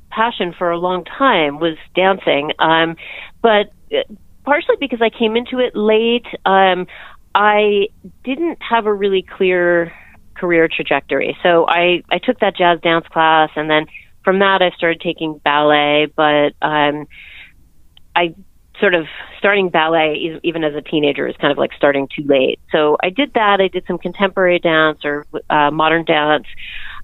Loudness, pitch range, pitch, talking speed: -15 LUFS, 155-200 Hz, 175 Hz, 160 wpm